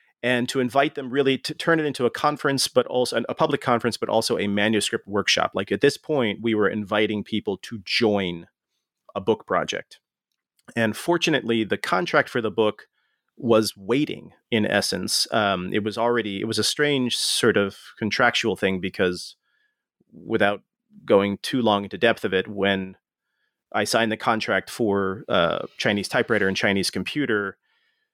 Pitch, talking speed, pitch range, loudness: 115 Hz, 165 wpm, 105-140 Hz, -23 LUFS